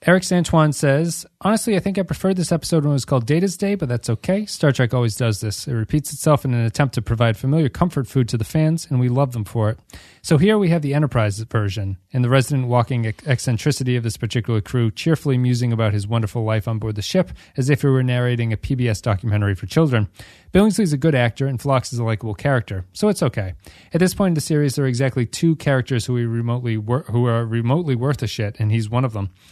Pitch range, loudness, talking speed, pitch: 115-150 Hz, -20 LUFS, 235 wpm, 125 Hz